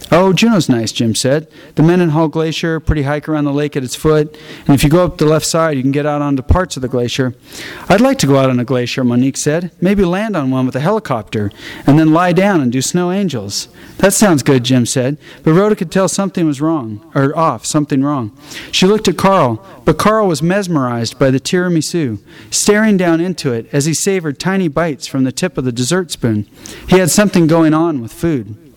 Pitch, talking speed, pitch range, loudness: 155 Hz, 225 wpm, 130-180 Hz, -14 LUFS